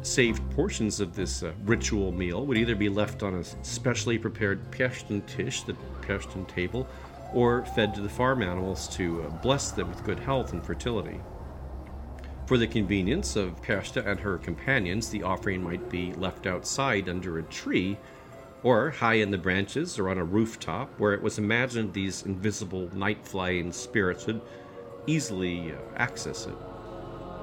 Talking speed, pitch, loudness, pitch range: 160 wpm, 100 Hz, -29 LUFS, 90-115 Hz